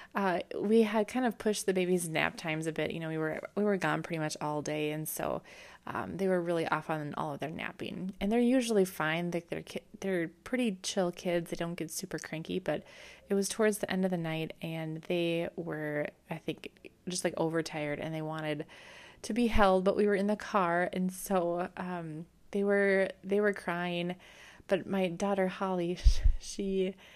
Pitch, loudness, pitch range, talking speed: 180 Hz, -32 LUFS, 160-200 Hz, 205 wpm